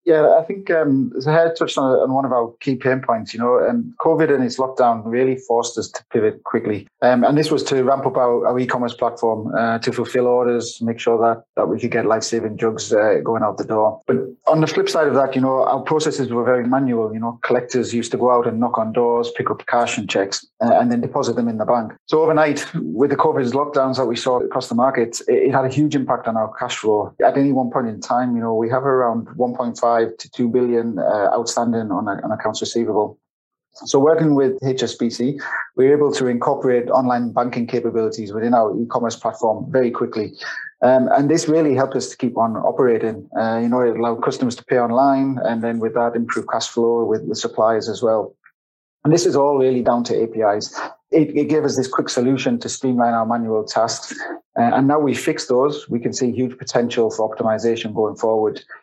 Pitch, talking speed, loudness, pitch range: 125 Hz, 230 wpm, -19 LUFS, 115-135 Hz